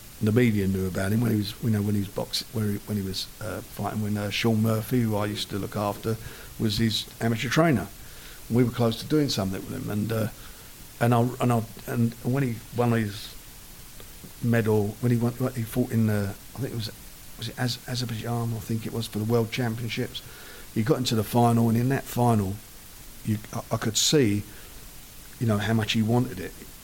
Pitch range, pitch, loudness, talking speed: 105-120 Hz, 115 Hz, -26 LUFS, 220 wpm